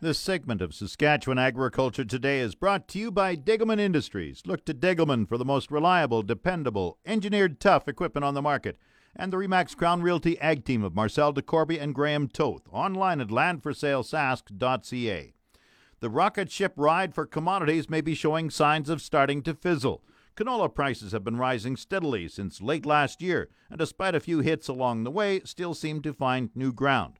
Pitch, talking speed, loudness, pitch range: 150 Hz, 180 wpm, -27 LUFS, 130-170 Hz